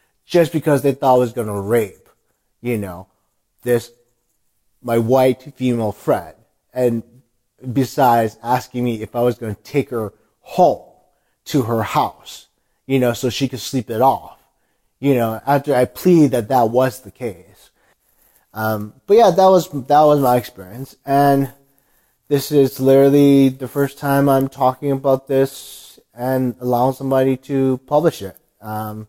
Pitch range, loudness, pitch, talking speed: 115-140 Hz, -17 LUFS, 130 Hz, 155 wpm